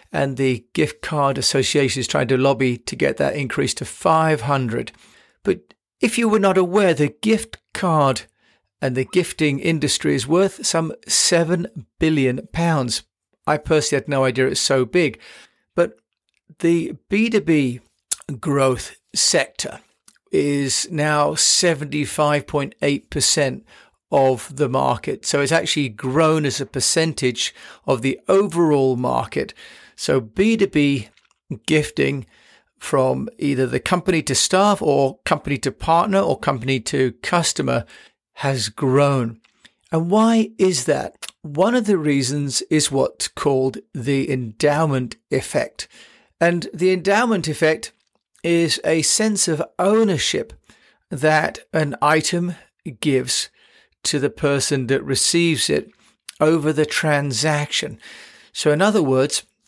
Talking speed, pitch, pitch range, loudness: 125 wpm, 150 Hz, 135-170 Hz, -19 LUFS